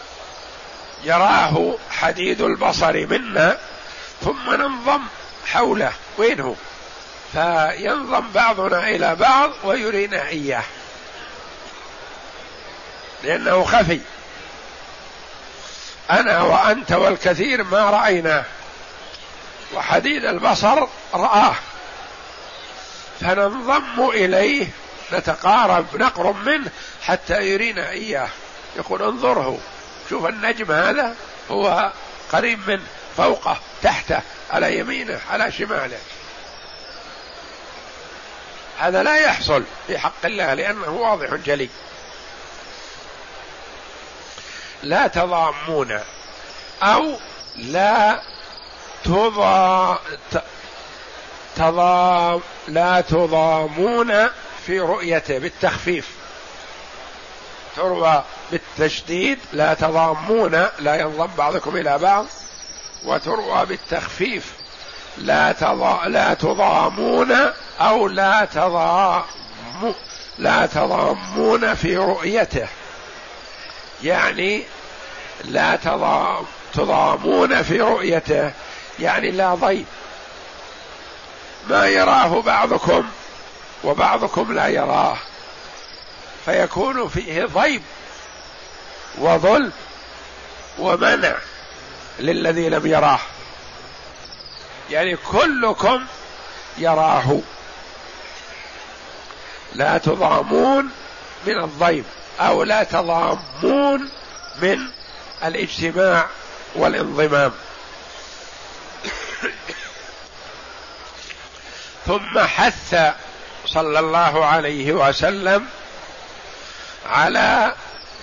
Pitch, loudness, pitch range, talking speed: 180 Hz, -18 LUFS, 160-205 Hz, 65 wpm